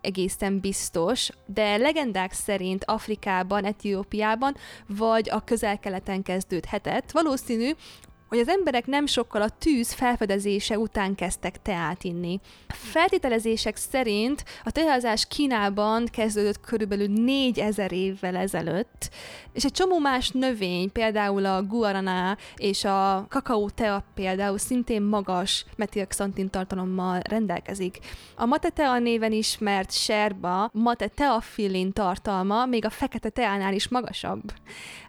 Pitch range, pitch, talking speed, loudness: 195-240 Hz, 210 Hz, 115 wpm, -26 LUFS